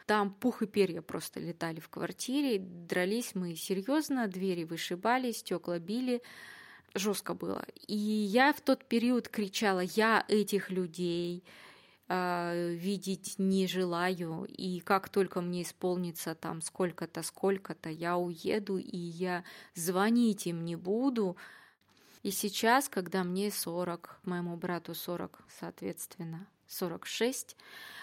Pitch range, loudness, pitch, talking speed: 175-210 Hz, -33 LUFS, 185 Hz, 120 wpm